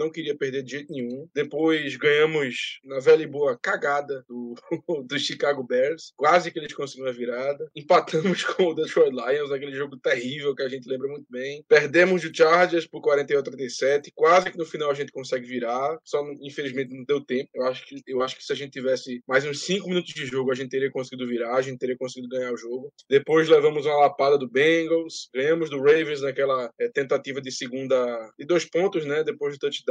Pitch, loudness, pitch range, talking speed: 145 Hz, -24 LUFS, 130-165 Hz, 210 wpm